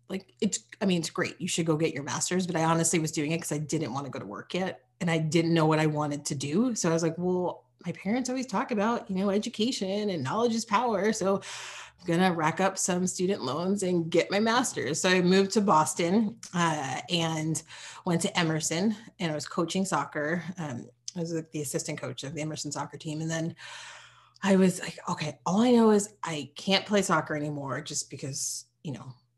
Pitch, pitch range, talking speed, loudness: 170 Hz, 155-195 Hz, 230 wpm, -28 LUFS